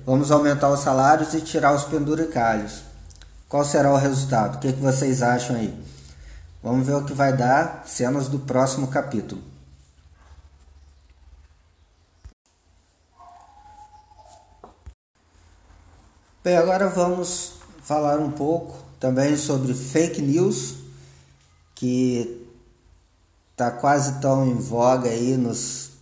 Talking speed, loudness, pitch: 105 wpm, -22 LUFS, 125 Hz